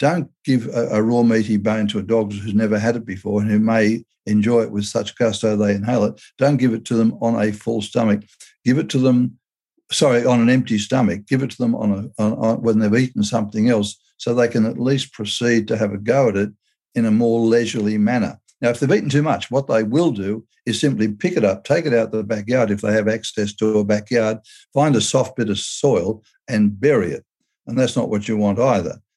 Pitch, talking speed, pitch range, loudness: 115 Hz, 245 wpm, 105-120 Hz, -19 LUFS